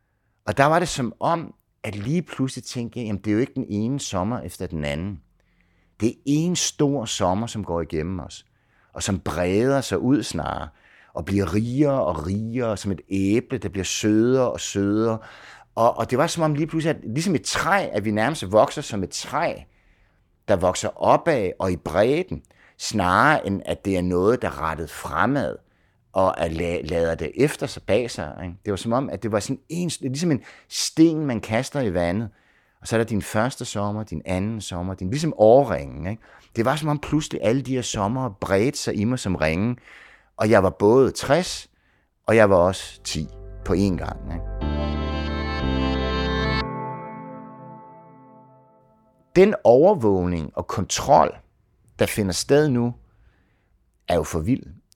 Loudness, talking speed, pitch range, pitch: -23 LUFS, 180 wpm, 90-125 Hz, 105 Hz